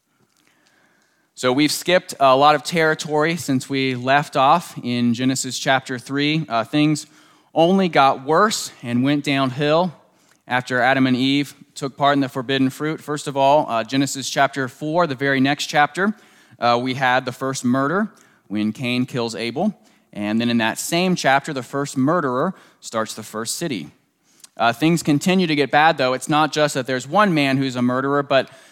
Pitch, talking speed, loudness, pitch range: 140 Hz, 180 wpm, -19 LUFS, 130-155 Hz